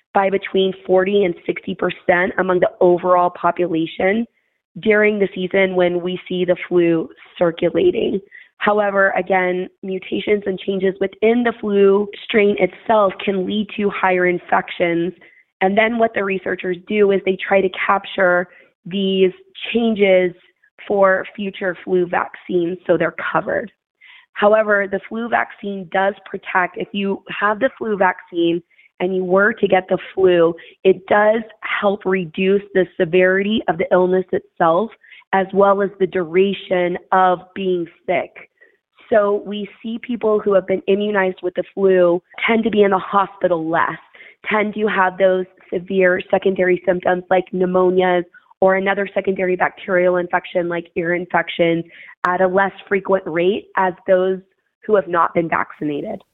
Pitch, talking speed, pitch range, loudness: 190 Hz, 145 wpm, 180-200 Hz, -18 LUFS